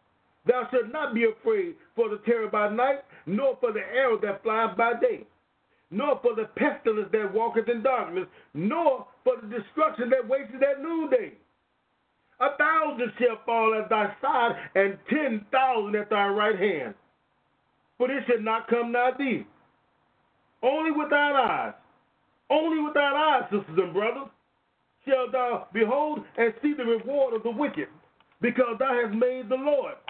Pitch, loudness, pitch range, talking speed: 250 Hz, -26 LUFS, 225-290 Hz, 165 wpm